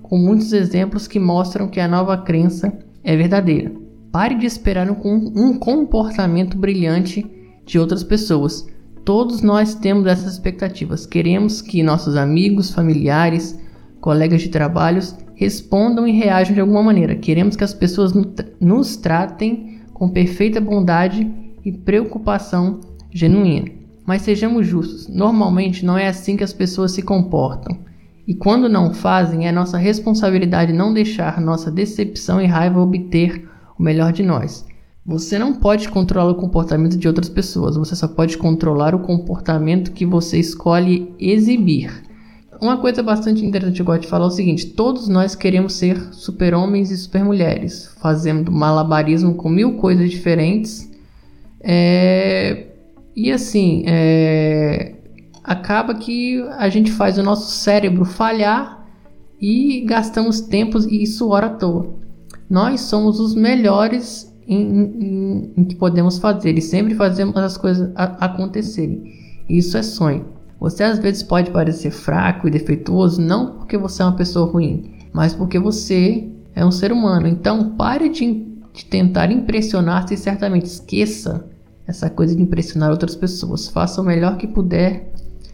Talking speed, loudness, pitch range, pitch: 145 wpm, -17 LUFS, 170-210 Hz, 185 Hz